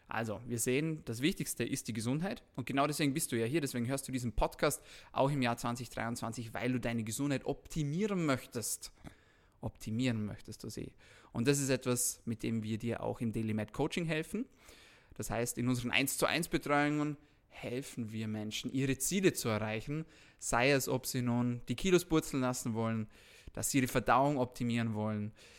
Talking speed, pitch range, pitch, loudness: 185 wpm, 115-145 Hz, 125 Hz, -35 LUFS